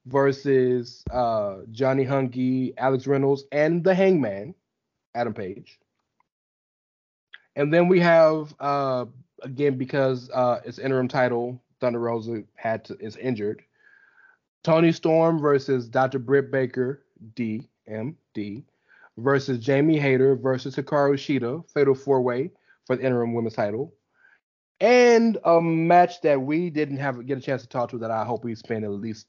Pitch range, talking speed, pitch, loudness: 125-145 Hz, 135 wpm, 135 Hz, -23 LUFS